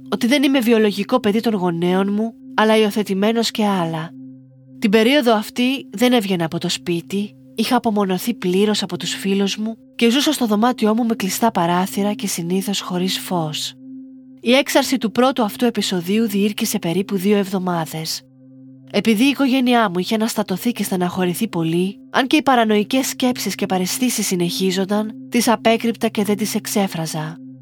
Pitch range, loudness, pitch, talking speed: 185-235 Hz, -18 LUFS, 210 Hz, 155 wpm